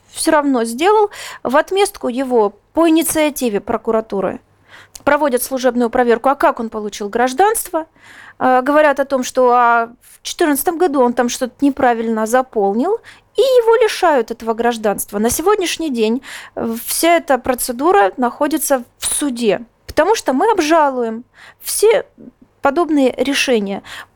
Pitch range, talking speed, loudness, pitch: 235-320 Hz, 130 wpm, -16 LUFS, 260 Hz